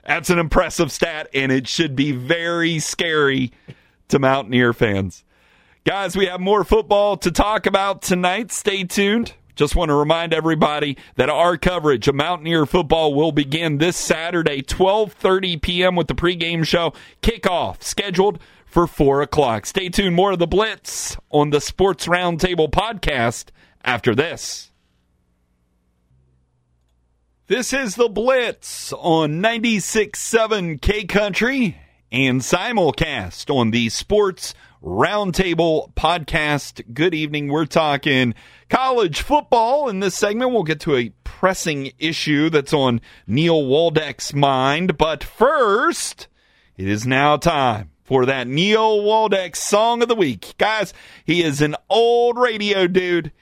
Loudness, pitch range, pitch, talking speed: -19 LUFS, 140-195 Hz, 165 Hz, 135 wpm